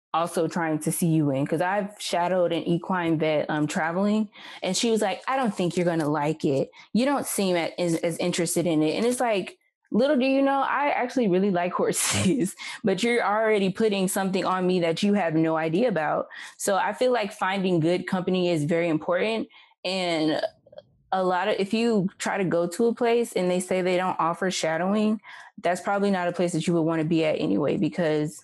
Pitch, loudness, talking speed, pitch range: 185 Hz, -25 LUFS, 215 wpm, 165-215 Hz